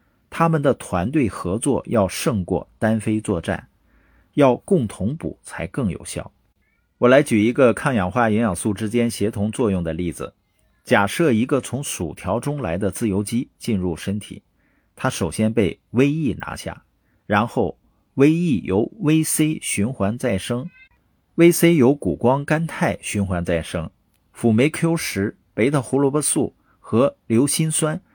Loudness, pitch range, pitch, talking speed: -20 LUFS, 100-150 Hz, 120 Hz, 215 characters per minute